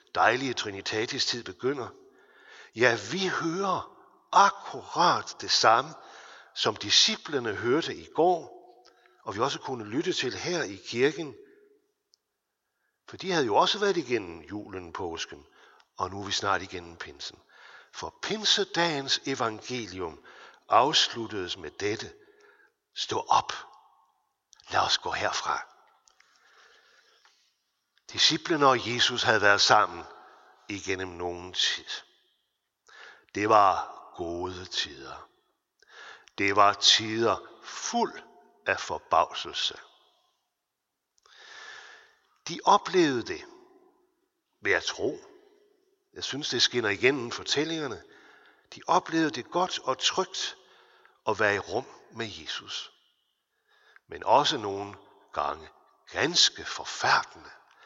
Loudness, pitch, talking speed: -27 LUFS, 360 Hz, 105 wpm